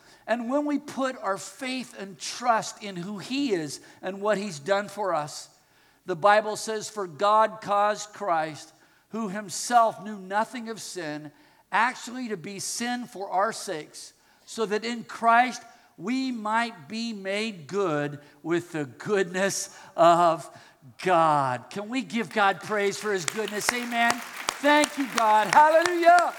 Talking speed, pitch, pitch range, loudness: 150 wpm, 215 Hz, 195-235 Hz, -26 LUFS